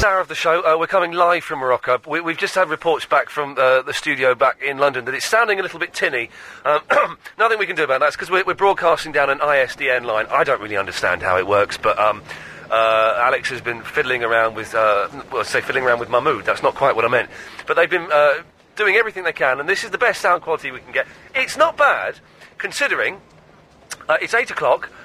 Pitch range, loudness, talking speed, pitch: 135-185 Hz, -18 LUFS, 240 wpm, 160 Hz